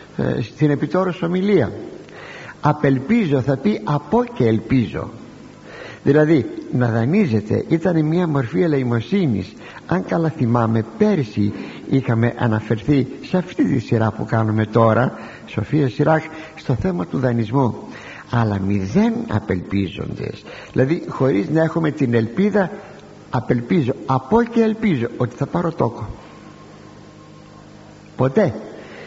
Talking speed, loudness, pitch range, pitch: 110 wpm, -19 LUFS, 110-160 Hz, 130 Hz